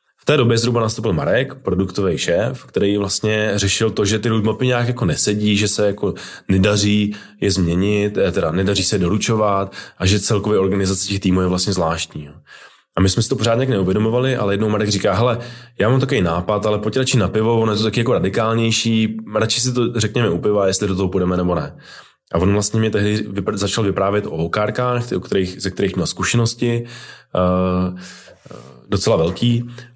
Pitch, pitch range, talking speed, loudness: 105 Hz, 95-115 Hz, 185 wpm, -17 LUFS